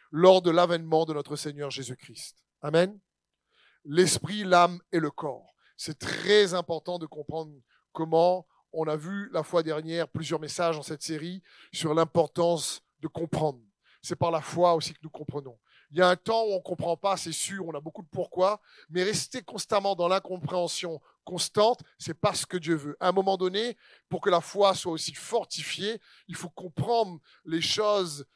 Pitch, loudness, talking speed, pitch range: 170 Hz, -28 LUFS, 185 wpm, 155-185 Hz